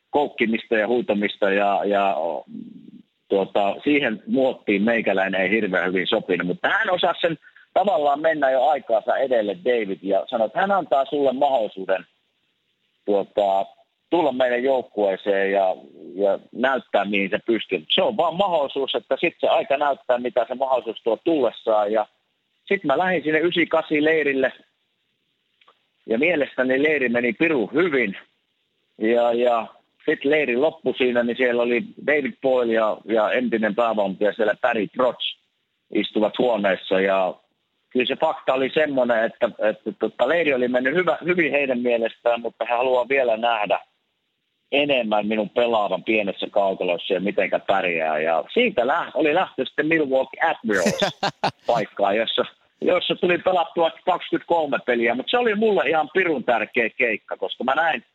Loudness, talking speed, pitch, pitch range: -21 LUFS, 150 wpm, 125 Hz, 110-155 Hz